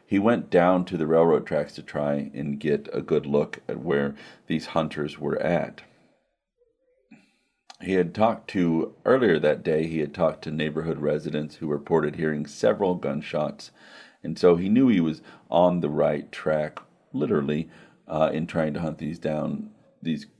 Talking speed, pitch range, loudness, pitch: 170 wpm, 75-85 Hz, -25 LUFS, 80 Hz